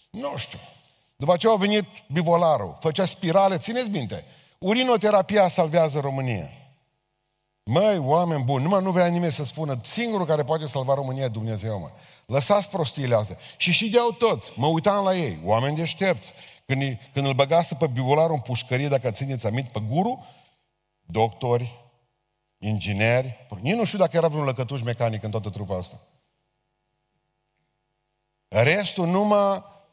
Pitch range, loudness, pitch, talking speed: 125-180 Hz, -23 LUFS, 140 Hz, 145 wpm